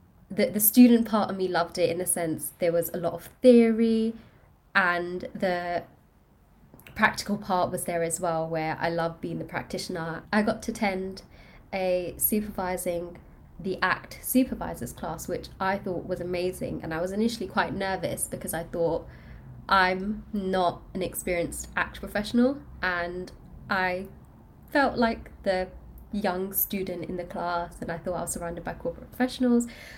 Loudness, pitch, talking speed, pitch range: -27 LUFS, 185 Hz, 160 wpm, 175-210 Hz